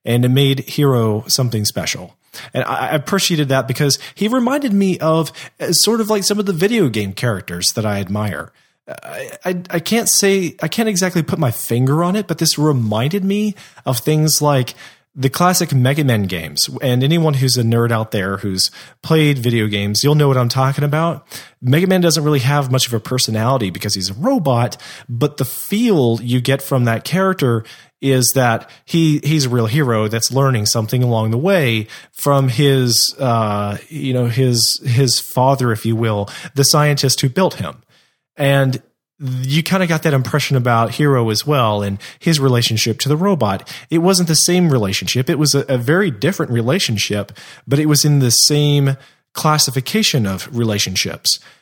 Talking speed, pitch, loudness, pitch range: 180 wpm, 135 Hz, -16 LUFS, 115-160 Hz